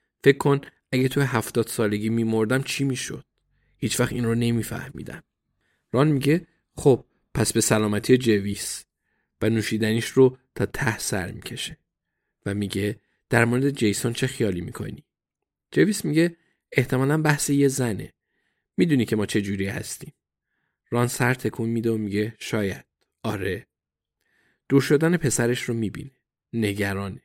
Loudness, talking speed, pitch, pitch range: -24 LUFS, 135 wpm, 120 Hz, 110-135 Hz